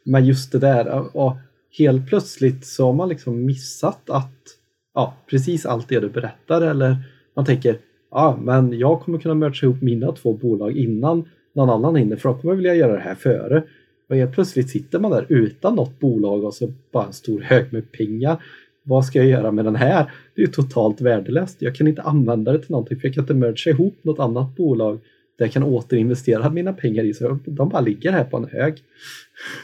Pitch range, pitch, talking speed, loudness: 120-155 Hz, 130 Hz, 215 wpm, -19 LUFS